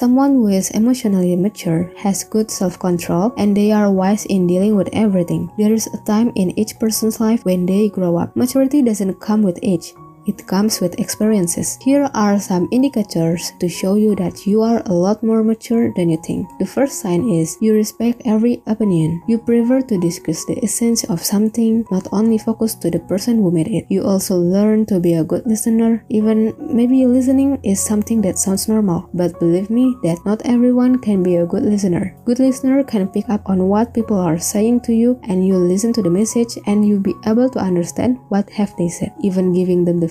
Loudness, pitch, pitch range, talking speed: -16 LUFS, 210 Hz, 185-230 Hz, 205 wpm